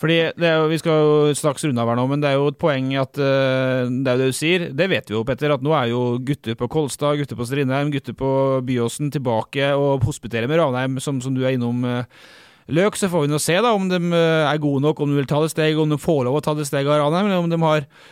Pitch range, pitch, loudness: 130-155 Hz, 145 Hz, -20 LUFS